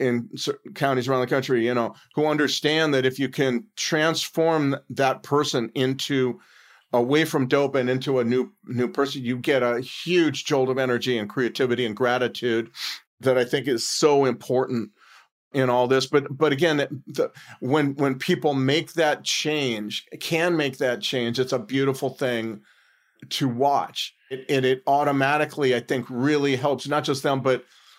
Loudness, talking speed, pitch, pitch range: -23 LUFS, 170 wpm, 135 Hz, 125-145 Hz